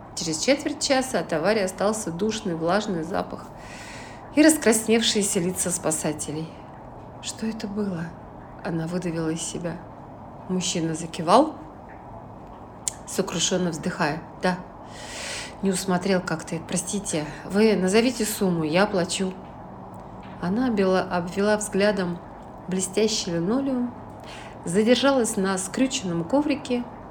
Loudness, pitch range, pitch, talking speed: -24 LUFS, 170-220 Hz, 190 Hz, 95 wpm